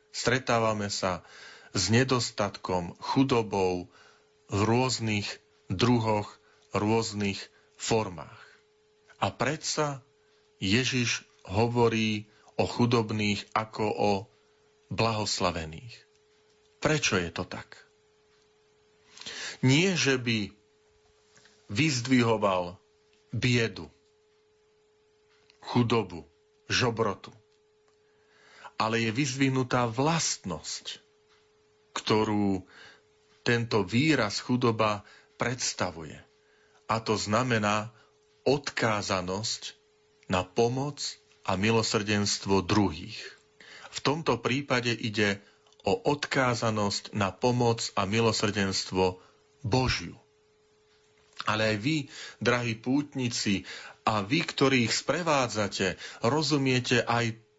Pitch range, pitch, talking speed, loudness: 105-140 Hz, 115 Hz, 75 wpm, -28 LUFS